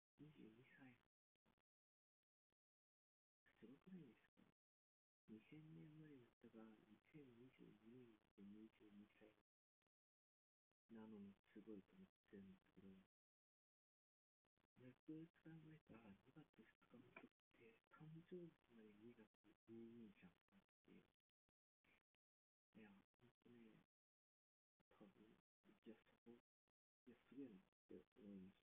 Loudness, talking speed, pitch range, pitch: -66 LUFS, 160 characters per minute, 105-150 Hz, 115 Hz